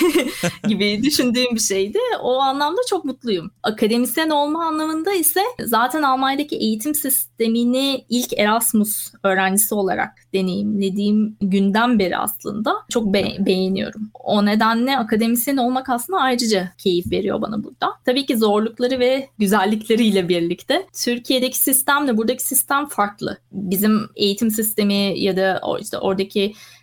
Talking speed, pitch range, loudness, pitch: 125 wpm, 205-270 Hz, -19 LUFS, 230 Hz